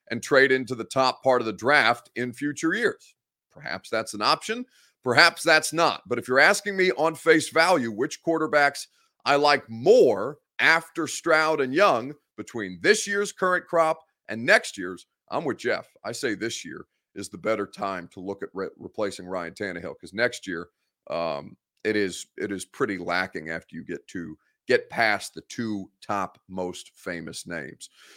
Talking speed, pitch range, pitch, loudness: 180 wpm, 120-170 Hz, 155 Hz, -24 LUFS